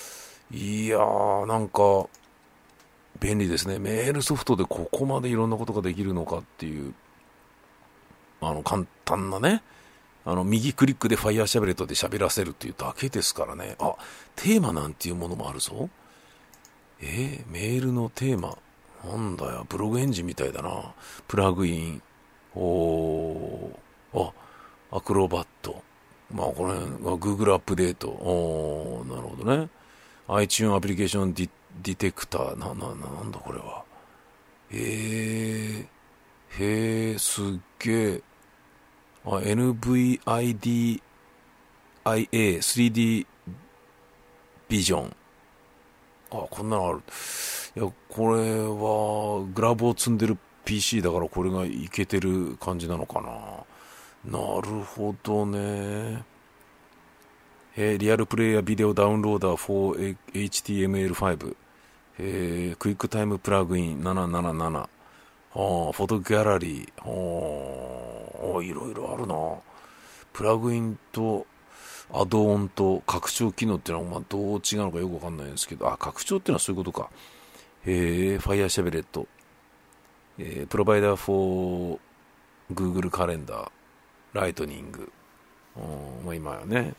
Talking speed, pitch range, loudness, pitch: 285 characters per minute, 85-110 Hz, -27 LUFS, 100 Hz